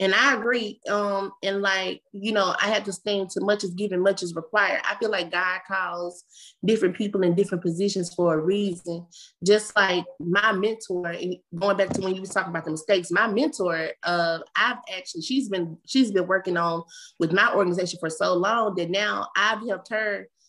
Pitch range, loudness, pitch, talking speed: 175-205 Hz, -24 LUFS, 190 Hz, 200 wpm